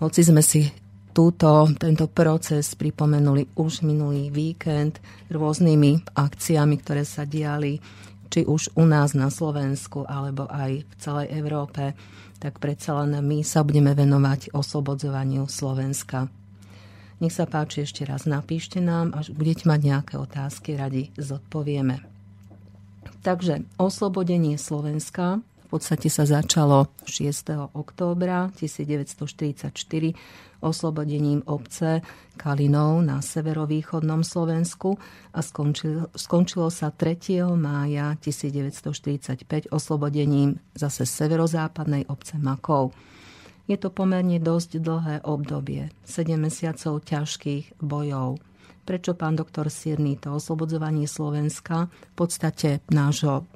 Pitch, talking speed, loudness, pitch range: 150 Hz, 110 wpm, -24 LUFS, 140-160 Hz